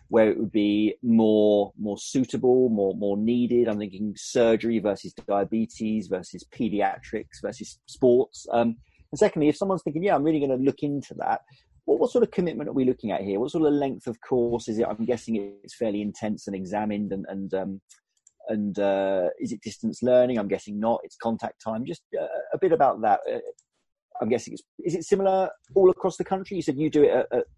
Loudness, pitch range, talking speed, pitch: -25 LUFS, 105-150 Hz, 210 wpm, 115 Hz